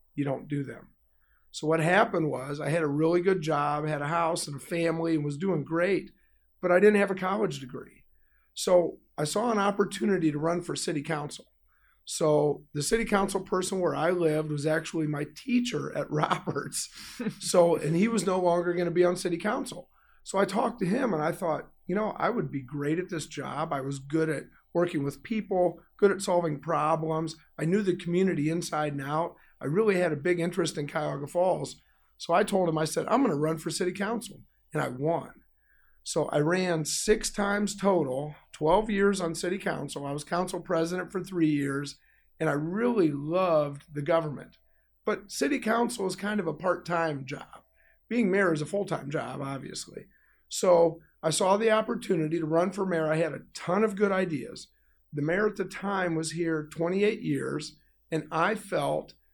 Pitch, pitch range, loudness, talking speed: 170 Hz, 150-195 Hz, -28 LUFS, 200 wpm